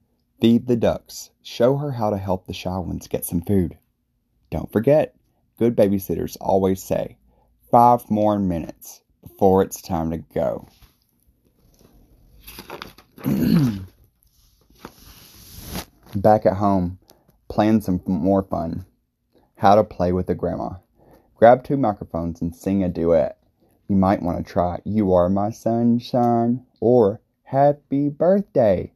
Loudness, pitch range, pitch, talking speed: -20 LUFS, 90-110 Hz, 95 Hz, 125 wpm